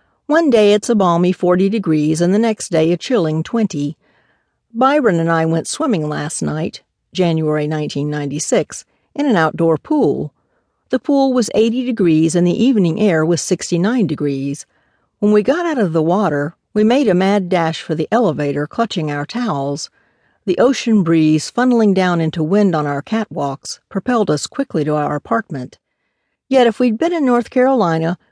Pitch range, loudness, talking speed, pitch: 155-230 Hz, -16 LUFS, 175 wpm, 180 Hz